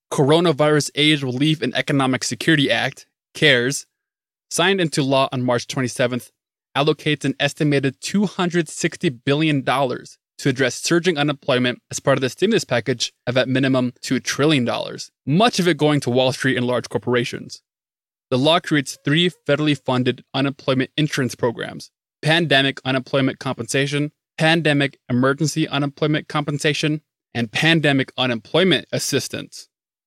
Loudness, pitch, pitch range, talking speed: -19 LUFS, 140 Hz, 130-155 Hz, 130 wpm